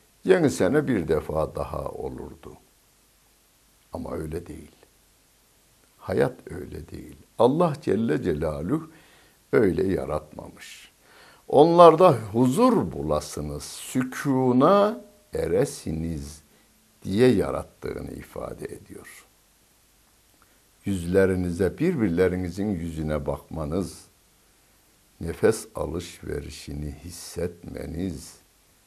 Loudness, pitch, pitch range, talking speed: -24 LUFS, 95 Hz, 80-130 Hz, 70 wpm